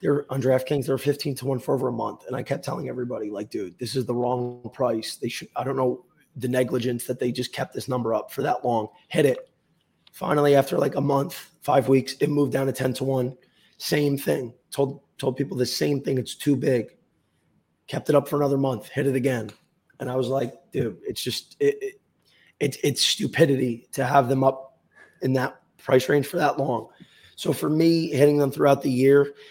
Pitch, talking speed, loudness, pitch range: 135 Hz, 220 wpm, -24 LUFS, 130-145 Hz